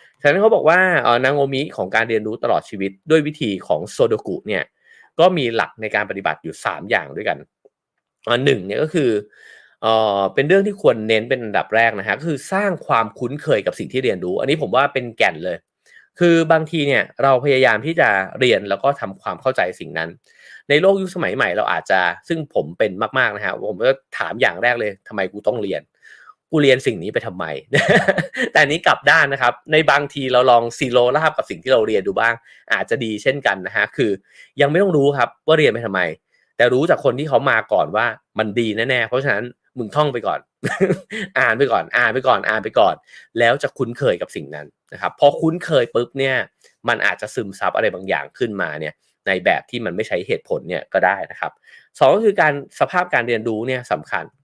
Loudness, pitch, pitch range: -18 LUFS, 140 Hz, 120-170 Hz